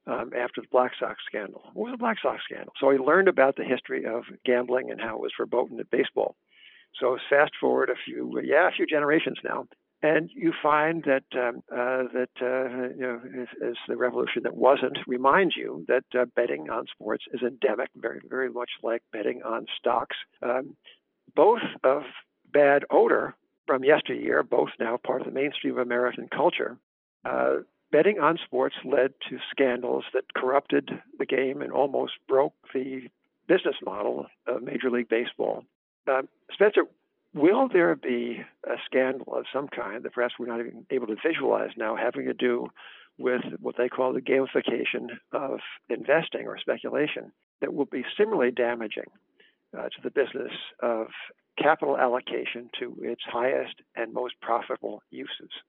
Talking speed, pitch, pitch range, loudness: 170 wpm, 125 Hz, 120-135 Hz, -27 LUFS